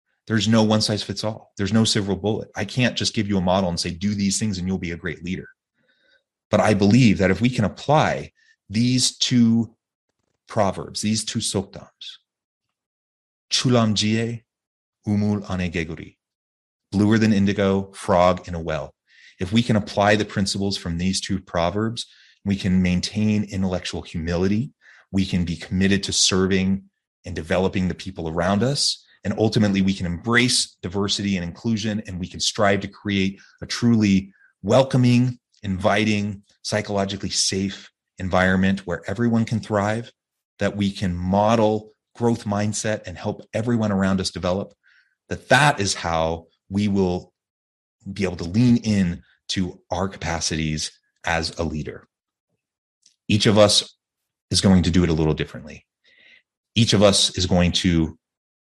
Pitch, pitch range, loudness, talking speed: 100 Hz, 90-110 Hz, -21 LUFS, 155 wpm